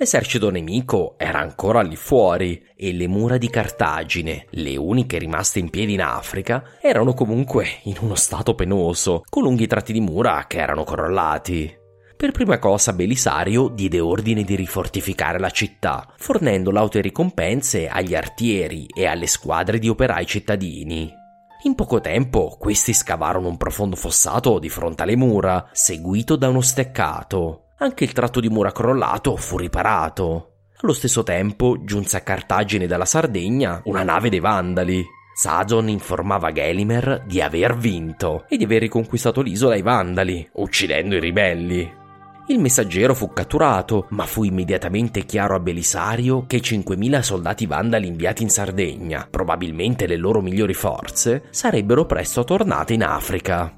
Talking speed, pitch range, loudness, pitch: 150 wpm, 90-115 Hz, -20 LUFS, 100 Hz